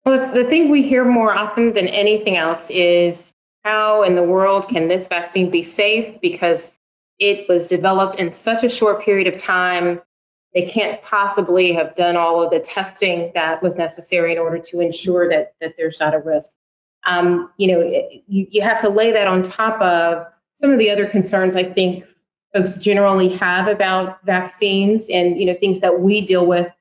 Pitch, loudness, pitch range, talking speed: 185 Hz, -17 LUFS, 175-205 Hz, 190 wpm